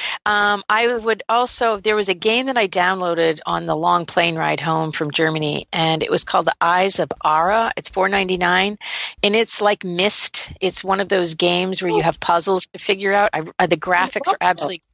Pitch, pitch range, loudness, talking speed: 185 Hz, 170-205 Hz, -18 LUFS, 220 wpm